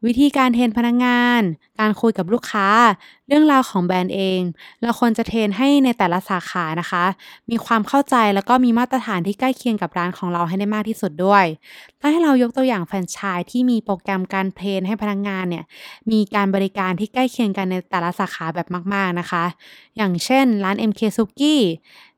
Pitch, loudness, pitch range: 205 Hz, -19 LUFS, 185-240 Hz